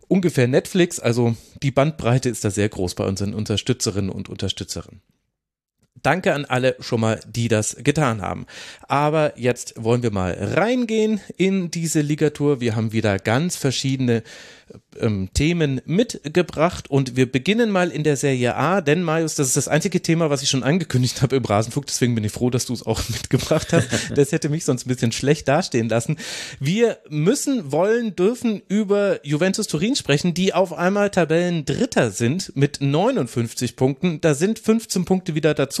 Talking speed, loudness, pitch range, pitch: 175 wpm, -21 LUFS, 120-175 Hz, 140 Hz